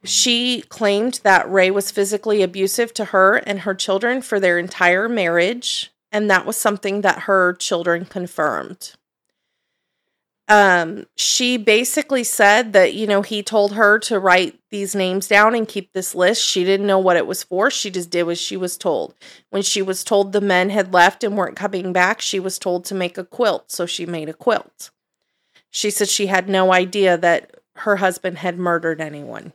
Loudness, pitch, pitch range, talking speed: -17 LUFS, 195 Hz, 180-210 Hz, 190 wpm